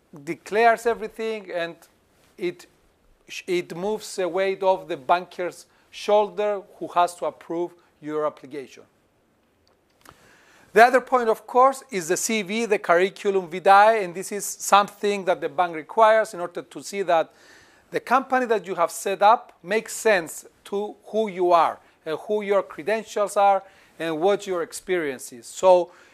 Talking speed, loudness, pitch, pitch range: 150 wpm, -23 LUFS, 195 Hz, 175-215 Hz